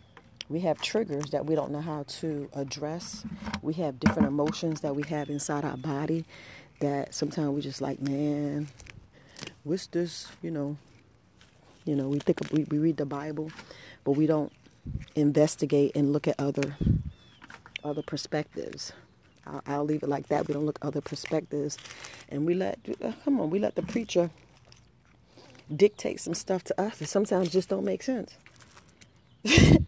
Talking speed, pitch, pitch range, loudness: 165 wpm, 150 Hz, 145-165 Hz, -30 LUFS